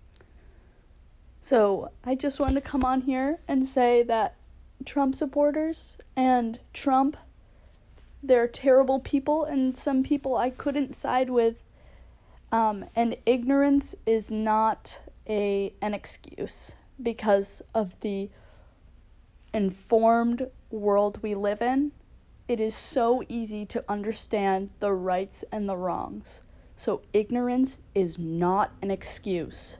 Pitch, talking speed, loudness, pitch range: 230 Hz, 115 wpm, -26 LUFS, 200-265 Hz